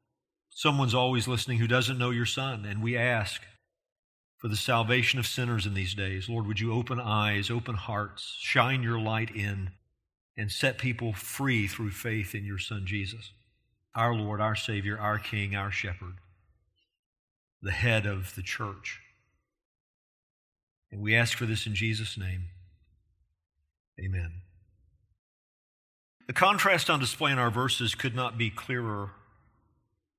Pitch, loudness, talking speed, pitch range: 110 Hz, -29 LUFS, 145 wpm, 100-120 Hz